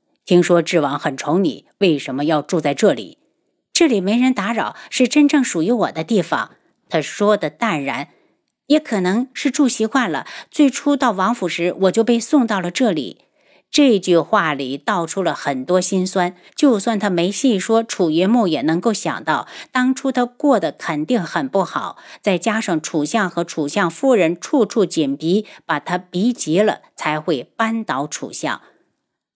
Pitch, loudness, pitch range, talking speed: 205 Hz, -18 LUFS, 170-245 Hz, 240 characters per minute